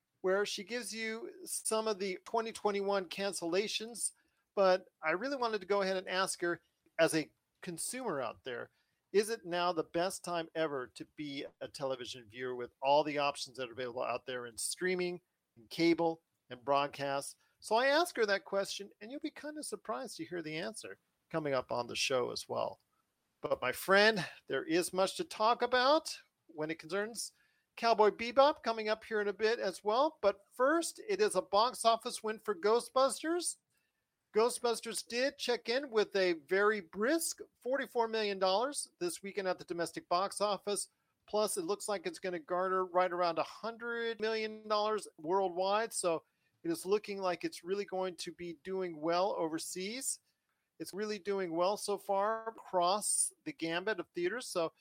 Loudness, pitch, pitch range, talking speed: -35 LUFS, 200 Hz, 170-225 Hz, 175 wpm